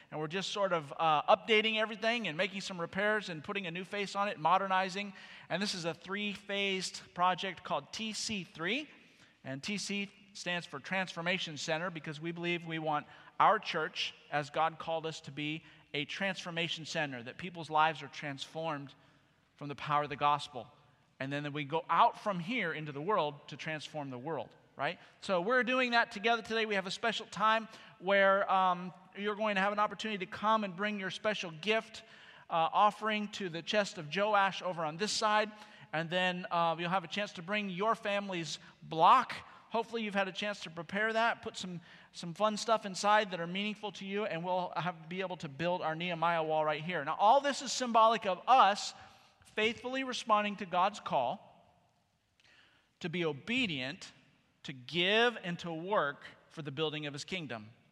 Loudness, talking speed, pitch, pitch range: -33 LUFS, 190 wpm, 185 Hz, 160-210 Hz